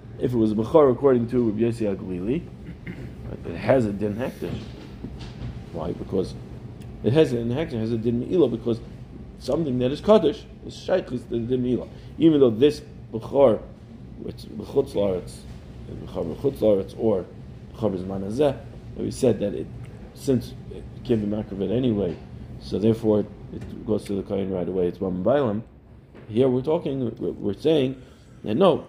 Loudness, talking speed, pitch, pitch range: -24 LUFS, 160 wpm, 115 Hz, 105-130 Hz